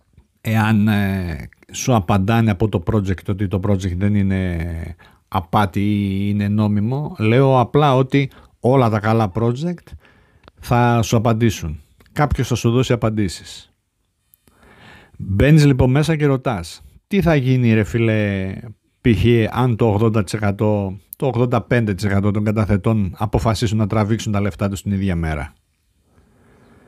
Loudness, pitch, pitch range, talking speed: -18 LUFS, 105 Hz, 100-120 Hz, 125 wpm